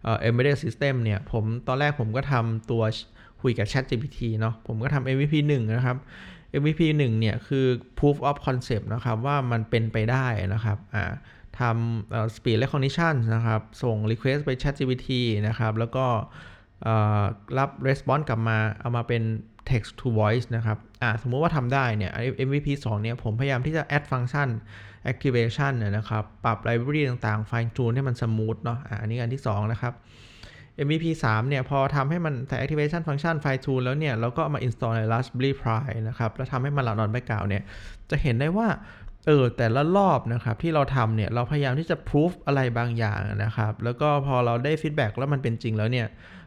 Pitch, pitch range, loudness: 120 Hz, 110-140 Hz, -26 LUFS